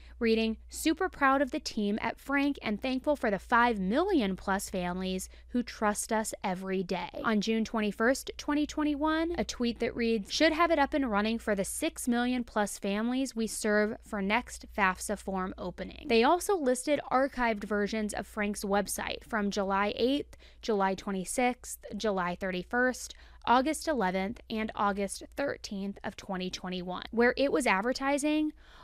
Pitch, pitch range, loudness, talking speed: 225 Hz, 200-270 Hz, -30 LUFS, 155 wpm